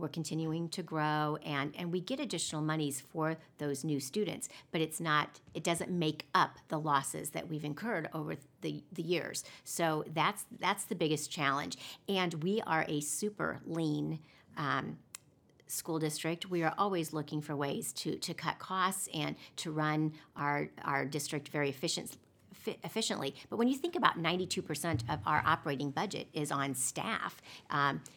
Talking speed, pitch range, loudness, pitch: 175 wpm, 150-175 Hz, -35 LUFS, 155 Hz